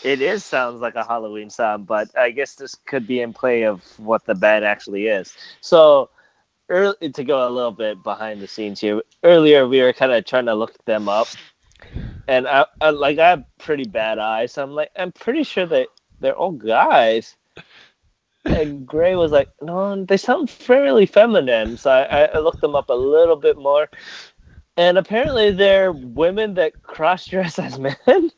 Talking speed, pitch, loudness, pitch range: 190 wpm, 145 Hz, -18 LUFS, 120-190 Hz